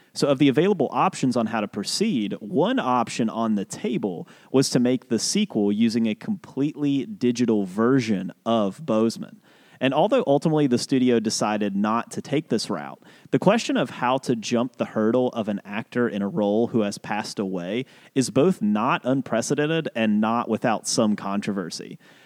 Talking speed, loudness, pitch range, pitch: 175 wpm, -23 LUFS, 110-140 Hz, 120 Hz